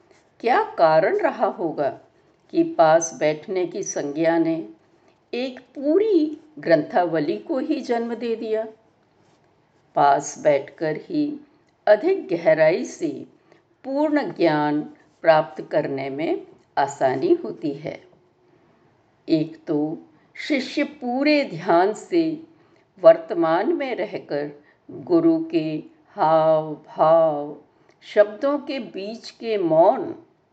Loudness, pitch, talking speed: -21 LUFS, 275 Hz, 100 wpm